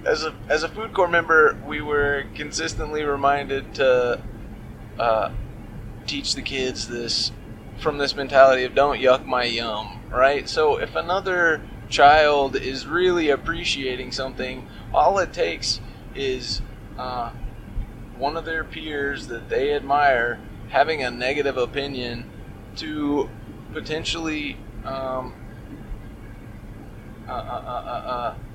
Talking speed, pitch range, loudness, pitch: 120 wpm, 115-150 Hz, -22 LUFS, 130 Hz